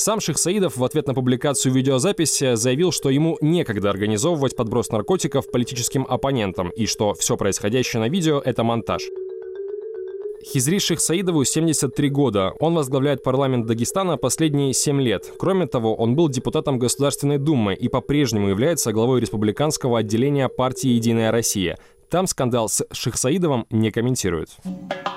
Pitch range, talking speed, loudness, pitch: 115-160 Hz, 135 wpm, -21 LUFS, 135 Hz